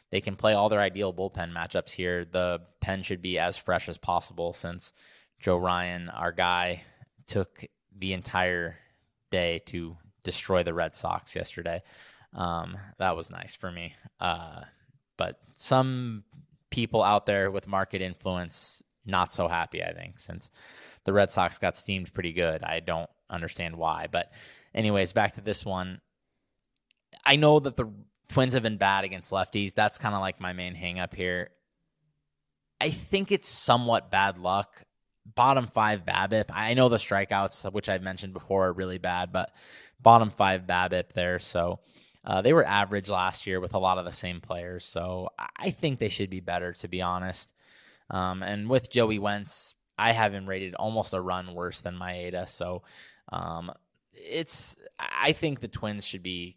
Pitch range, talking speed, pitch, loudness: 90-110 Hz, 170 wpm, 95 Hz, -28 LUFS